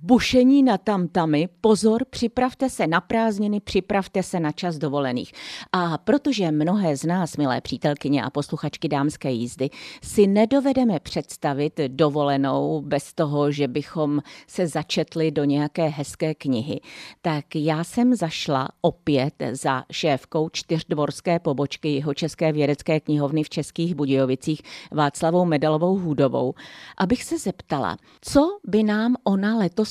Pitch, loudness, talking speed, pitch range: 160 Hz, -23 LUFS, 130 wpm, 145-195 Hz